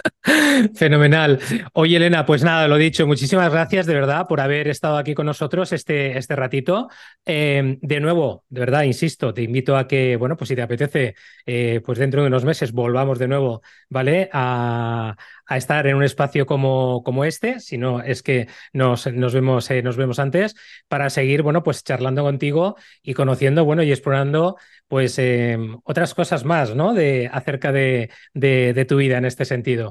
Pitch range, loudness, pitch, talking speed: 130-155 Hz, -19 LUFS, 140 Hz, 185 wpm